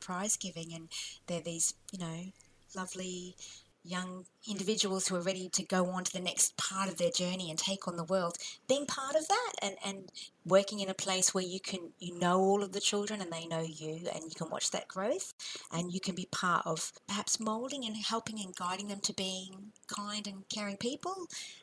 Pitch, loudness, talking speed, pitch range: 190 Hz, -35 LUFS, 210 wpm, 180-205 Hz